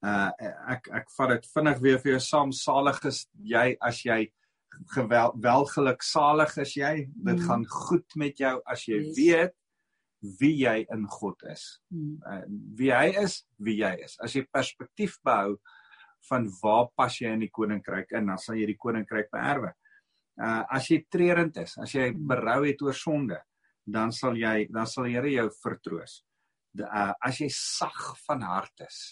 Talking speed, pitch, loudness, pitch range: 175 wpm, 130 Hz, -28 LUFS, 110-150 Hz